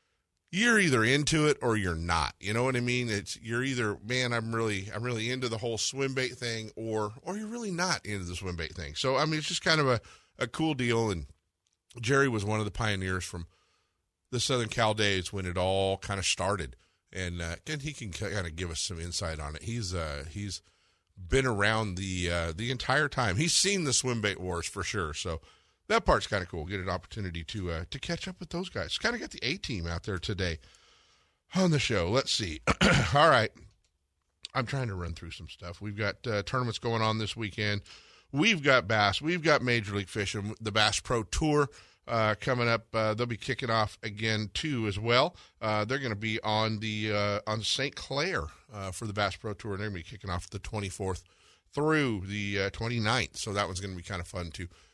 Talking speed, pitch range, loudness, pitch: 225 wpm, 95-120 Hz, -30 LUFS, 105 Hz